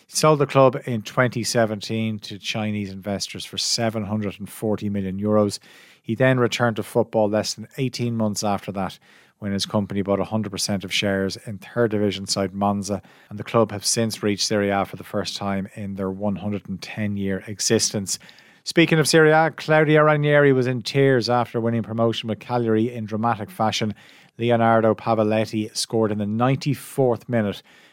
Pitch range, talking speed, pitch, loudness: 105-120 Hz, 165 wpm, 110 Hz, -22 LUFS